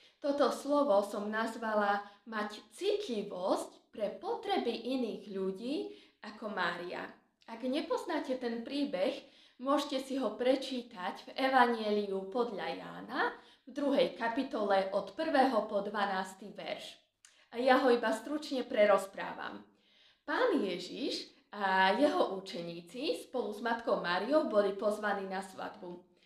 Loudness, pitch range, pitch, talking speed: -34 LUFS, 200-275 Hz, 235 Hz, 115 wpm